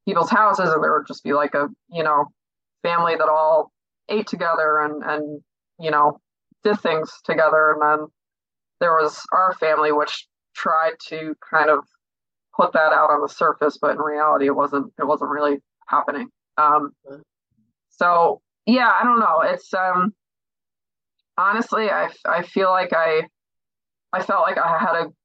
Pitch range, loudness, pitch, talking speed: 150-170 Hz, -20 LUFS, 155 Hz, 165 wpm